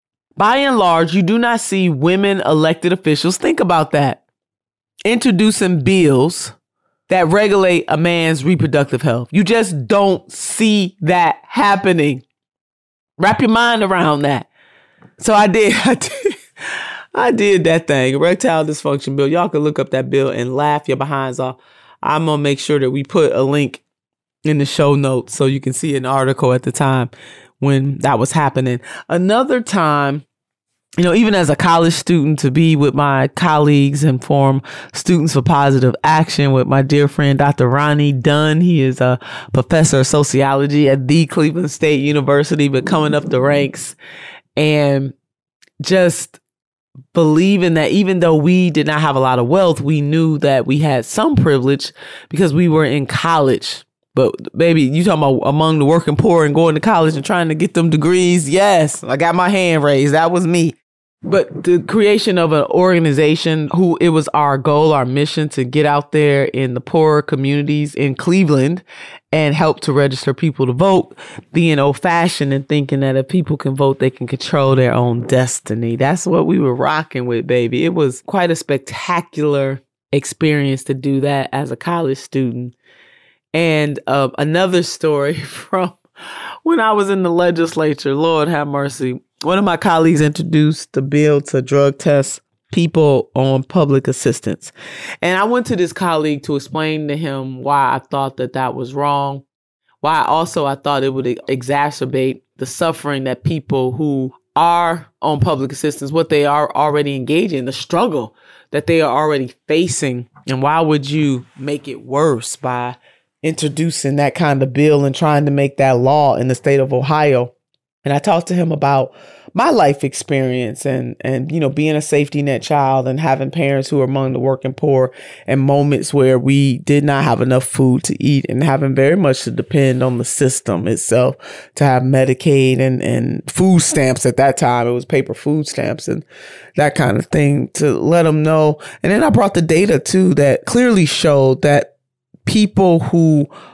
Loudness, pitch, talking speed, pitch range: -15 LUFS, 145 Hz, 180 wpm, 135-165 Hz